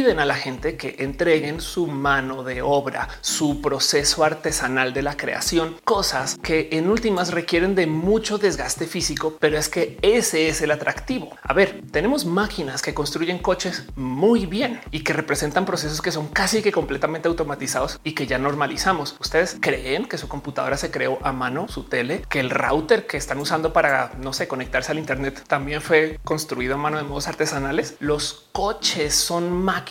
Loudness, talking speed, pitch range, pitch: -22 LUFS, 180 wpm, 145-175 Hz, 155 Hz